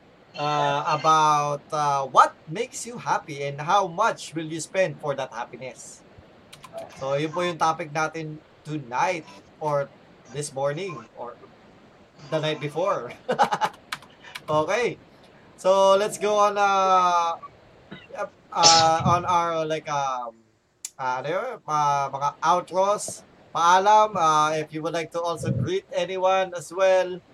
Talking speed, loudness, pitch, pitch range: 115 wpm, -23 LUFS, 160 Hz, 145-185 Hz